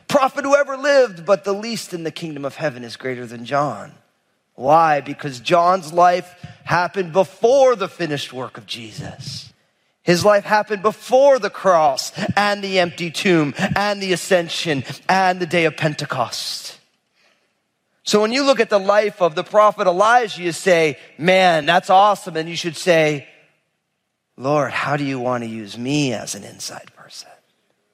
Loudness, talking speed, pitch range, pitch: -18 LUFS, 165 wpm, 145-200 Hz, 175 Hz